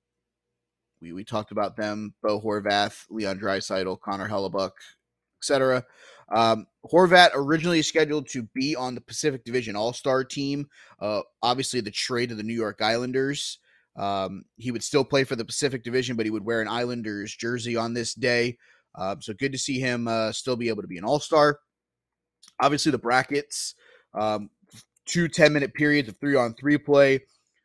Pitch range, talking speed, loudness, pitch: 105-140 Hz, 165 wpm, -25 LUFS, 120 Hz